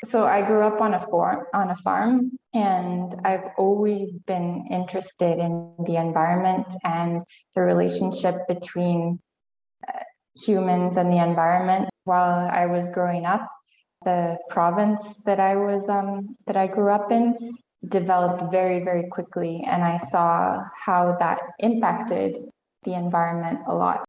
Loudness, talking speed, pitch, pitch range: -23 LUFS, 140 wpm, 185 Hz, 175-205 Hz